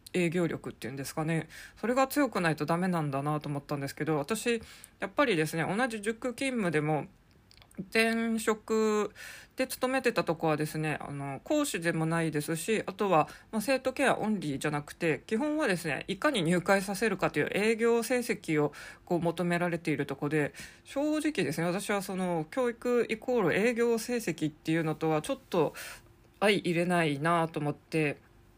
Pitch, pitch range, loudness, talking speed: 175 Hz, 155-225 Hz, -30 LUFS, 355 characters per minute